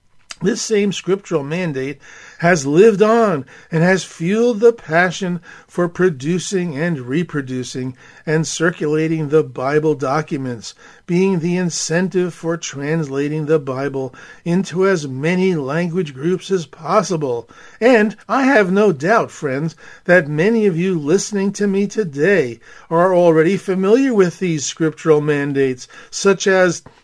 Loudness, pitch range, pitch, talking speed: -17 LUFS, 155-190 Hz, 175 Hz, 130 wpm